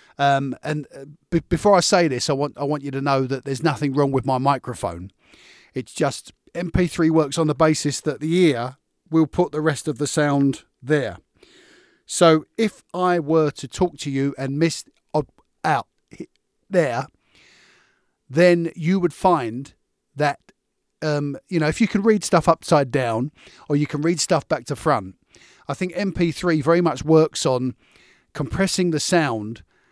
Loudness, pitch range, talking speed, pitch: -21 LUFS, 140-175 Hz, 170 wpm, 155 Hz